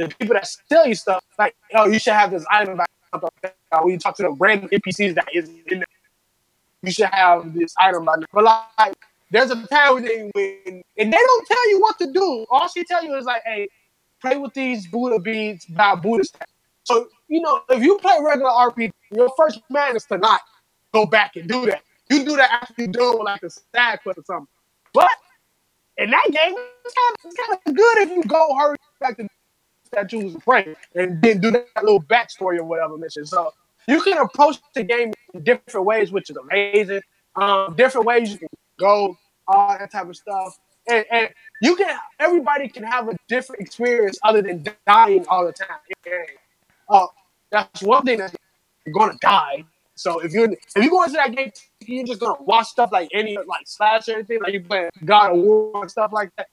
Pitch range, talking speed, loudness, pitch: 195-265 Hz, 215 wpm, -19 LUFS, 220 Hz